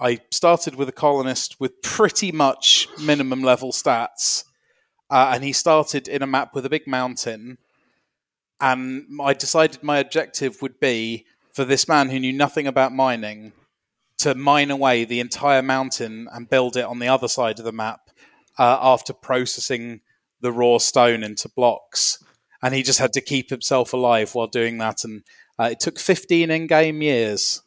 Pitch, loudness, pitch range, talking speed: 130 Hz, -20 LUFS, 120-140 Hz, 170 wpm